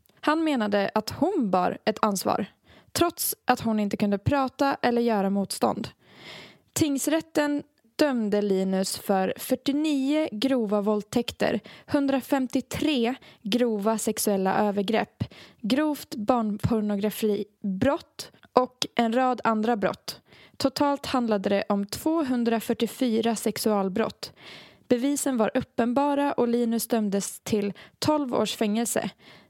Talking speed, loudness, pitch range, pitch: 100 wpm, -26 LUFS, 210-275 Hz, 235 Hz